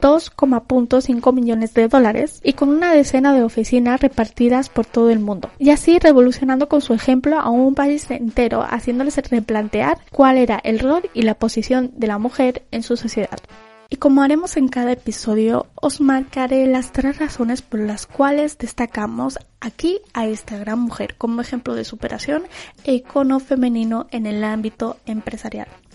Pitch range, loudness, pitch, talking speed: 230-275 Hz, -17 LUFS, 250 Hz, 165 wpm